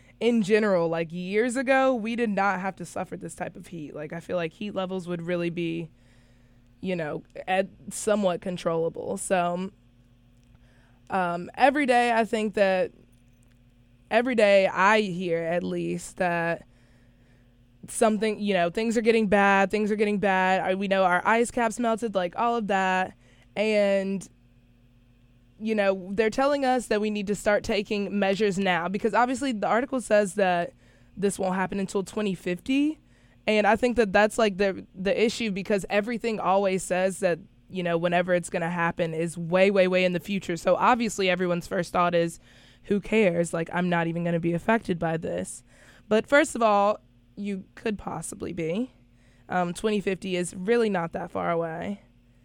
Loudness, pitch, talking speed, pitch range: -25 LUFS, 185 Hz, 175 wpm, 170-215 Hz